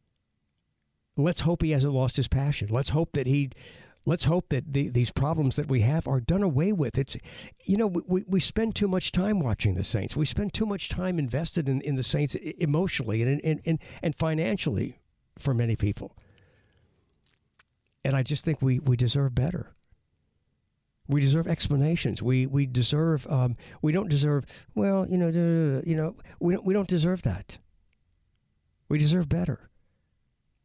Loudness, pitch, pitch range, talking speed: -27 LUFS, 145 Hz, 125-165 Hz, 170 wpm